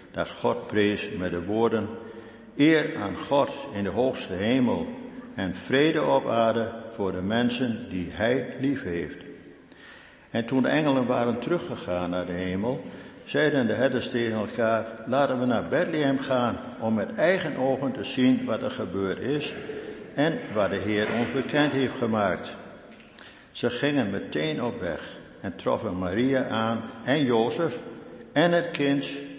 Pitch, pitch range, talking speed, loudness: 120 Hz, 110-140 Hz, 155 wpm, -26 LUFS